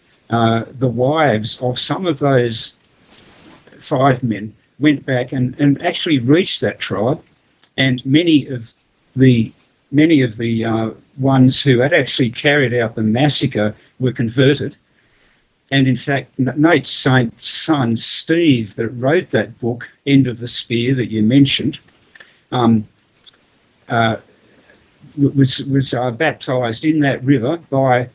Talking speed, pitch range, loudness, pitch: 135 wpm, 115-140 Hz, -16 LUFS, 130 Hz